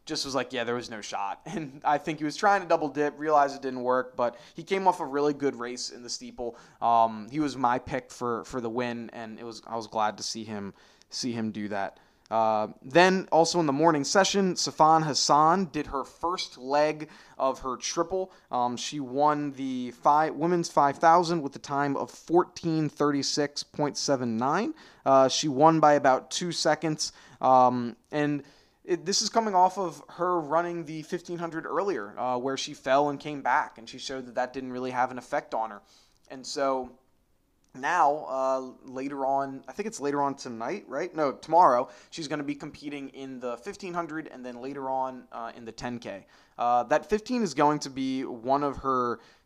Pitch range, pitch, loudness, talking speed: 125-160 Hz, 140 Hz, -27 LUFS, 195 wpm